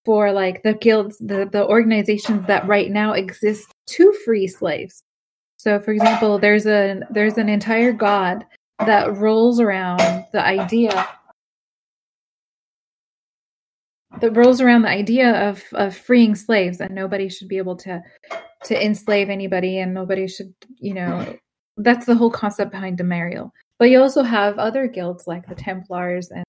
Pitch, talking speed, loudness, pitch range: 205 Hz, 150 wpm, -18 LUFS, 190-225 Hz